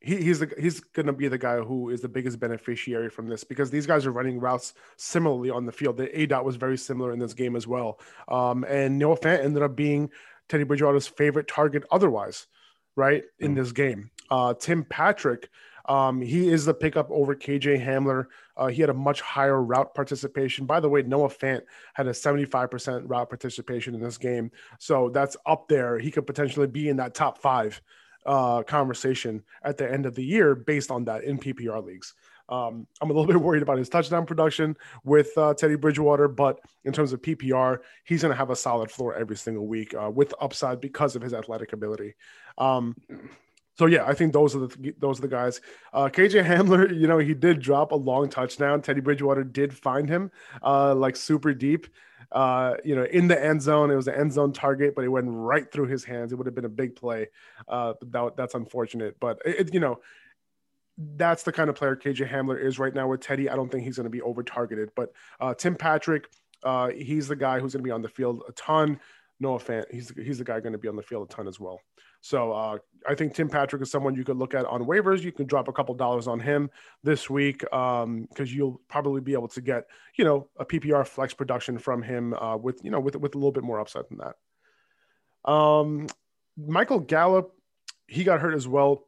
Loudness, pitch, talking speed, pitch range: -25 LUFS, 135 Hz, 225 wpm, 125-150 Hz